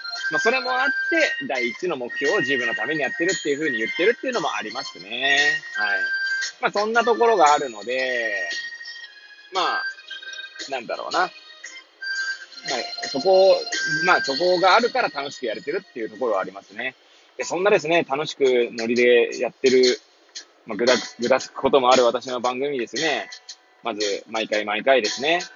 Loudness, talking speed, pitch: -21 LUFS, 340 characters per minute, 265 Hz